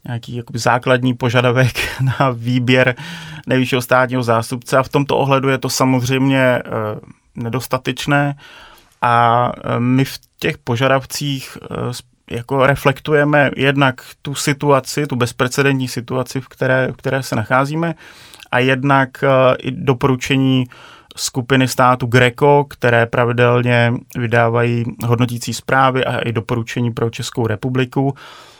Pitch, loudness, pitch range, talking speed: 130 Hz, -16 LUFS, 120-135 Hz, 110 wpm